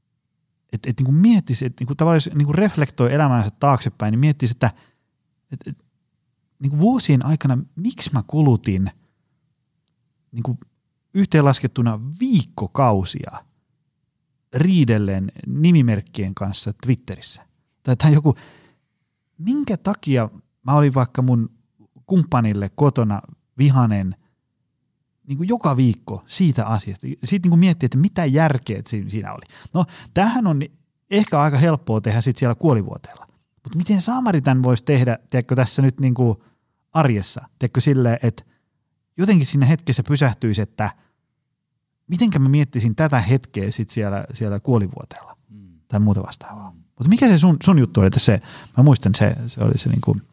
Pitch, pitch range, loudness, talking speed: 135 Hz, 115-155 Hz, -19 LUFS, 135 wpm